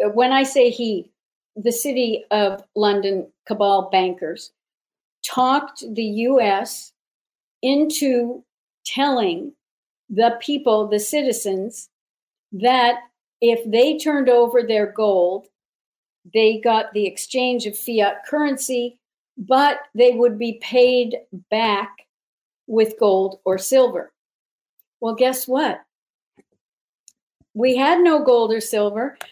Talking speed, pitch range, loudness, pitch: 105 wpm, 210-255 Hz, -19 LUFS, 235 Hz